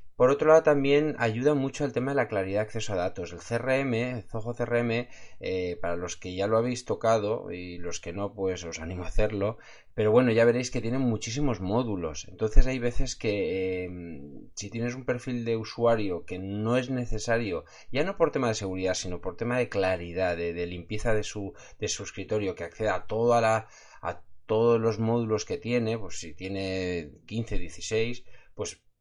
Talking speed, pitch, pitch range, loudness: 200 wpm, 110 Hz, 95-120 Hz, -28 LUFS